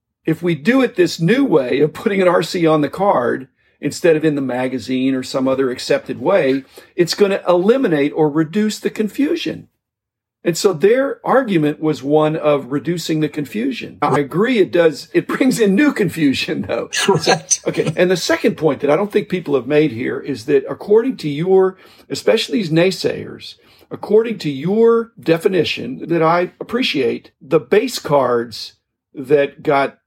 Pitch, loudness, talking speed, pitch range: 170 Hz, -17 LUFS, 170 wpm, 150-215 Hz